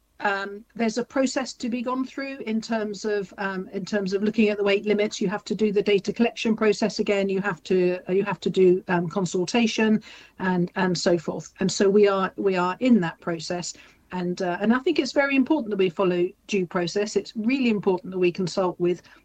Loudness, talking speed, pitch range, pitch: -24 LUFS, 225 wpm, 185-220 Hz, 200 Hz